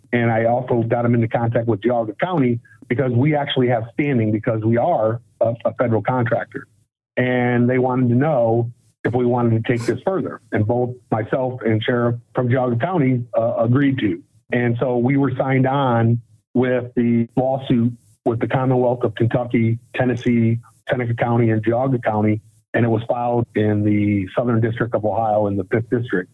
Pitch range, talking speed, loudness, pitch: 115-125 Hz, 180 wpm, -19 LUFS, 120 Hz